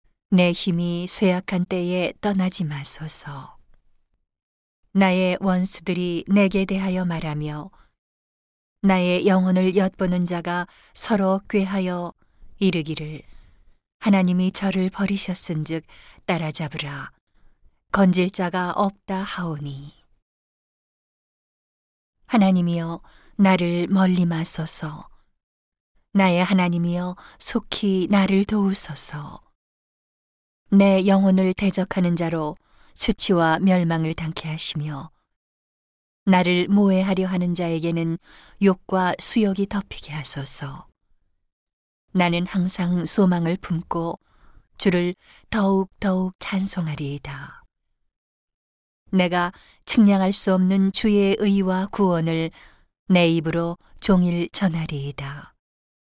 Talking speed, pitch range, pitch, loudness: 205 characters per minute, 165-195 Hz, 180 Hz, -22 LUFS